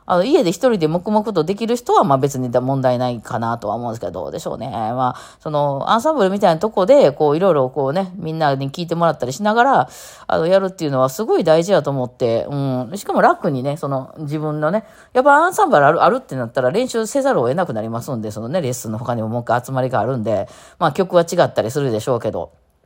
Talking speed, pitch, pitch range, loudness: 495 characters per minute, 150 Hz, 125-195 Hz, -18 LUFS